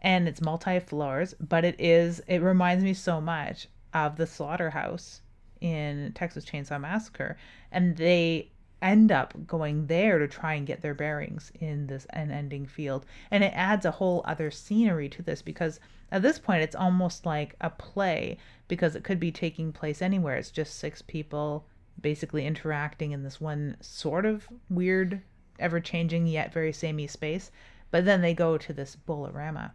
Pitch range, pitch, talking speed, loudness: 150-180 Hz, 165 Hz, 170 wpm, -29 LUFS